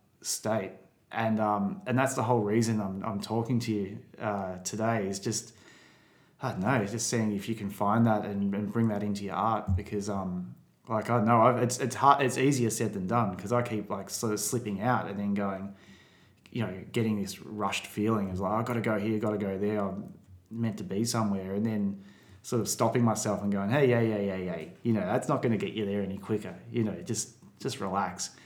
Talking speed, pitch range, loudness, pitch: 235 wpm, 100-115 Hz, -30 LUFS, 105 Hz